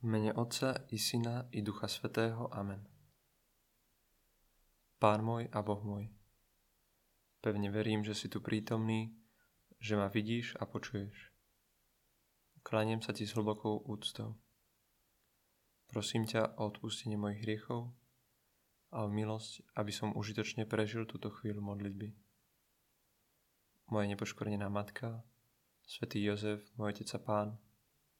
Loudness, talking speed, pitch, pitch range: -39 LUFS, 115 wpm, 110 Hz, 105-115 Hz